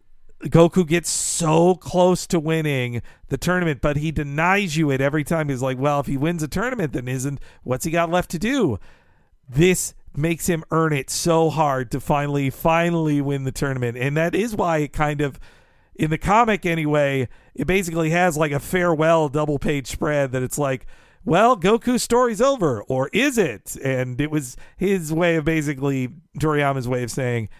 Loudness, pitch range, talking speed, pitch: -21 LUFS, 140-170 Hz, 185 wpm, 155 Hz